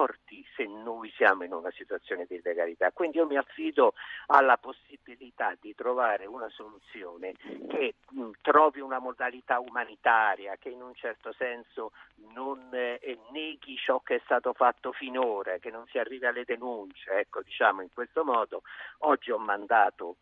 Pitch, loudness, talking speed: 270 Hz, -29 LUFS, 150 wpm